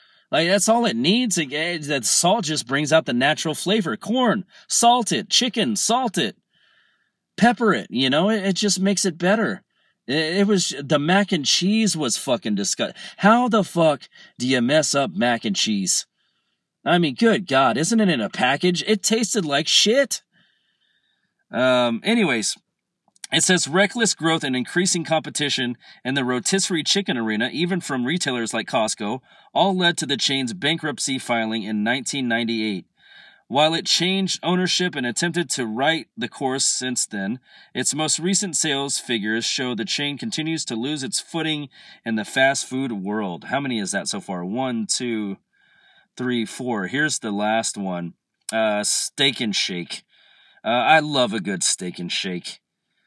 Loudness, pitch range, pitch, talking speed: -21 LUFS, 125-195 Hz, 155 Hz, 165 wpm